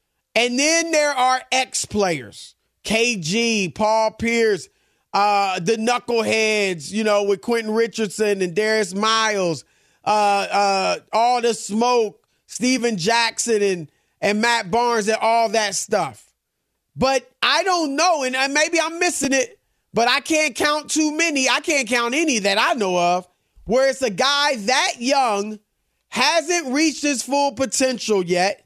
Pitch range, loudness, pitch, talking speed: 210-275 Hz, -19 LUFS, 230 Hz, 145 wpm